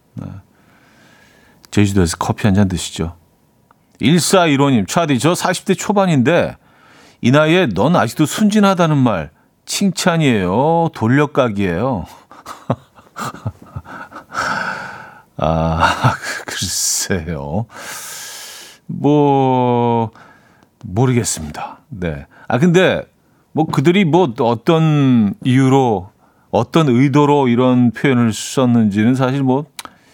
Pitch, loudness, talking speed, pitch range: 130 Hz, -15 LUFS, 185 characters per minute, 115-165 Hz